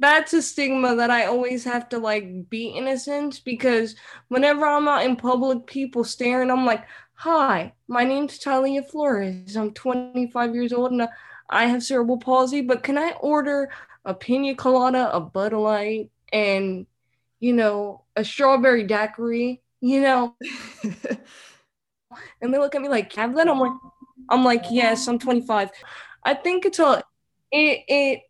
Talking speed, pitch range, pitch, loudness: 160 wpm, 230-275 Hz, 250 Hz, -22 LUFS